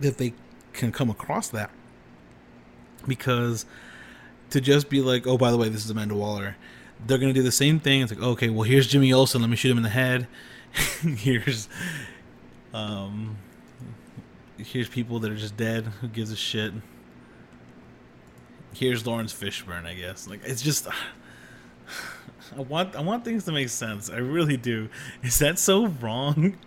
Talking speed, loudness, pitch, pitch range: 165 wpm, -25 LUFS, 115 Hz, 100-130 Hz